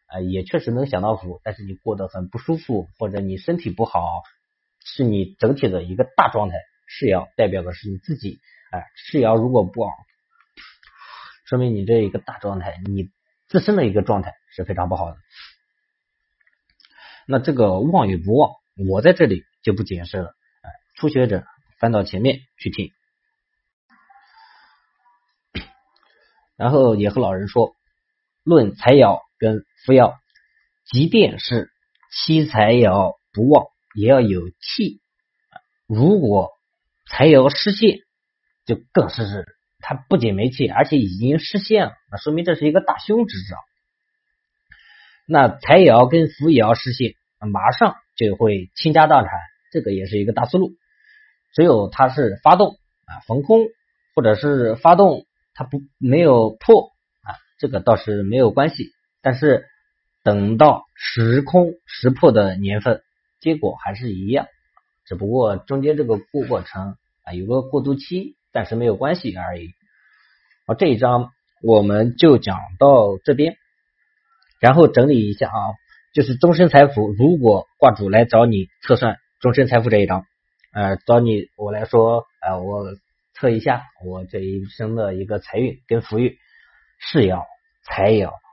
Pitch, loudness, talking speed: 120 Hz, -17 LUFS, 215 characters per minute